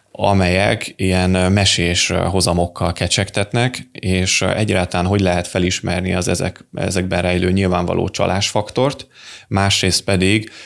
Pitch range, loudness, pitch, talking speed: 90-100 Hz, -17 LUFS, 95 Hz, 100 wpm